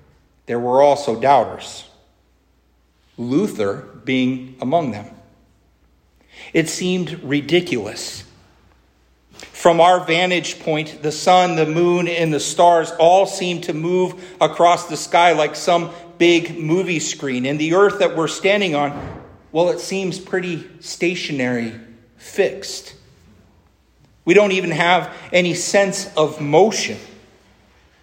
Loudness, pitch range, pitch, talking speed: -18 LUFS, 125-175 Hz, 160 Hz, 120 wpm